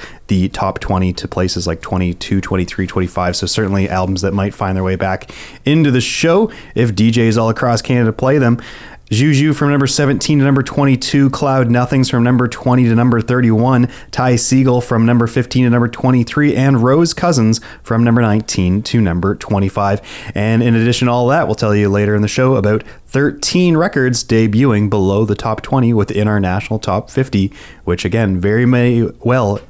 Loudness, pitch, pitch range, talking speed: -14 LUFS, 115 Hz, 100-130 Hz, 185 wpm